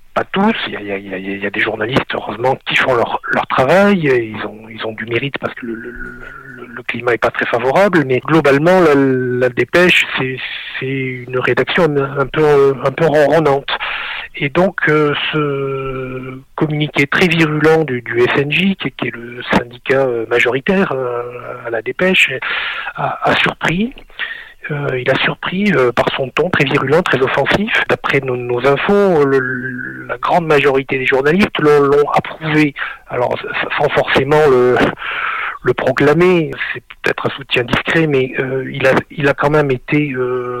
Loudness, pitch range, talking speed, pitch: -14 LUFS, 125-155 Hz, 175 wpm, 135 Hz